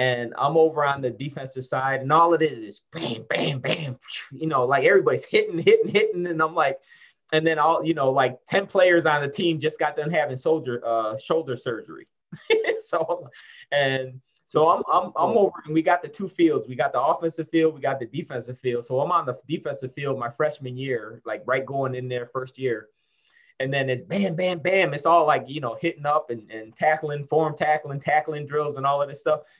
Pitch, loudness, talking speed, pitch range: 150 Hz, -23 LUFS, 215 wpm, 130-170 Hz